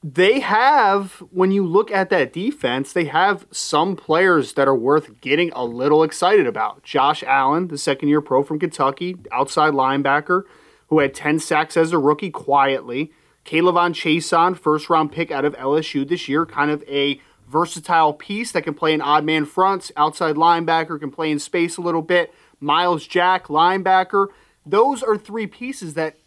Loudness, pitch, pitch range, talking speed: -19 LUFS, 160 Hz, 150-180 Hz, 180 wpm